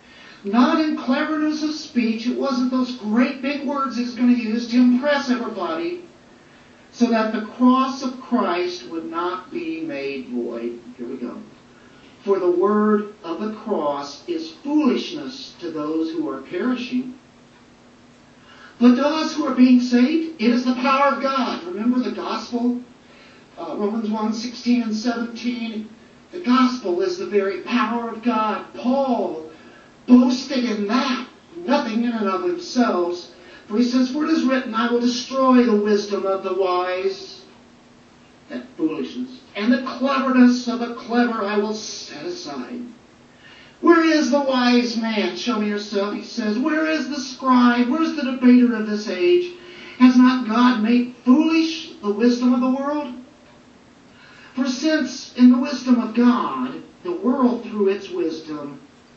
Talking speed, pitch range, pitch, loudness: 155 wpm, 215-270 Hz, 245 Hz, -20 LUFS